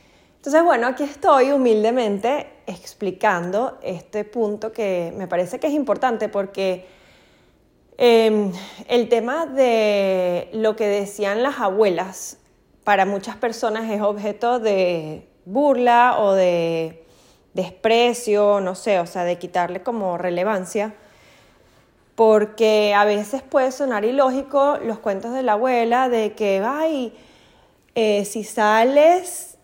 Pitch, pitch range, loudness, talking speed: 215 Hz, 195-245 Hz, -20 LUFS, 120 wpm